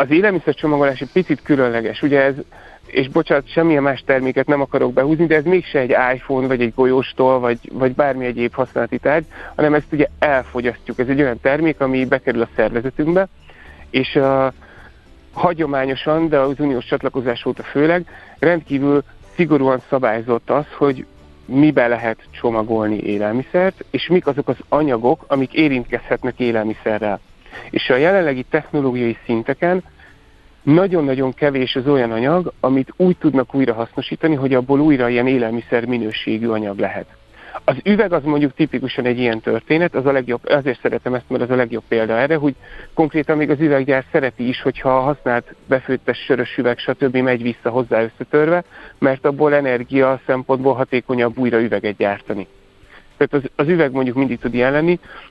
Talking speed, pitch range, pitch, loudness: 155 wpm, 120-150 Hz, 130 Hz, -18 LUFS